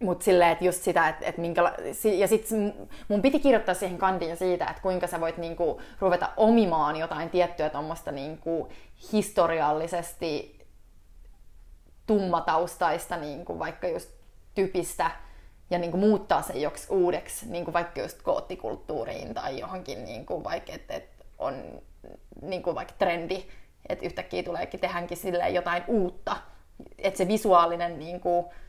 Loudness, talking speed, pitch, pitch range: -28 LUFS, 125 wpm, 175 Hz, 170-195 Hz